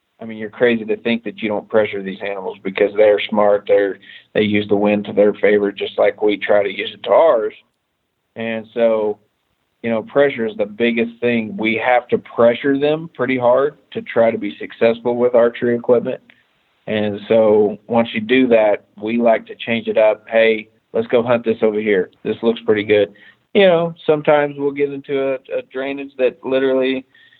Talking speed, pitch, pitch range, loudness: 195 wpm, 115 Hz, 110-135 Hz, -17 LUFS